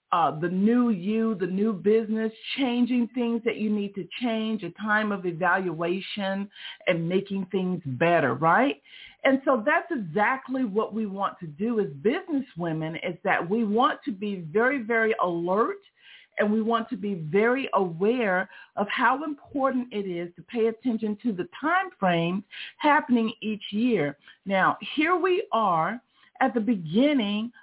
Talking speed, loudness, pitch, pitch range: 155 wpm, -26 LUFS, 215 Hz, 190-245 Hz